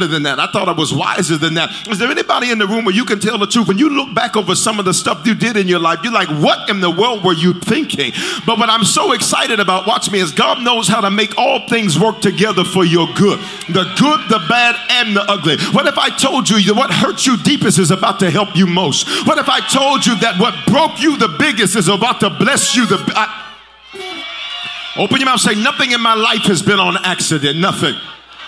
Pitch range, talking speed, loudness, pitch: 190-240 Hz, 255 wpm, -13 LUFS, 215 Hz